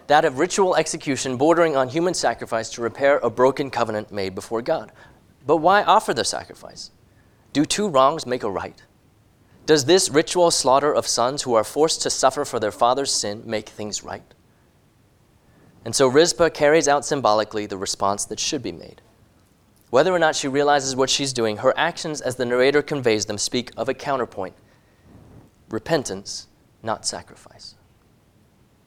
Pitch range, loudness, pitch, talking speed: 105-145 Hz, -21 LUFS, 120 Hz, 165 wpm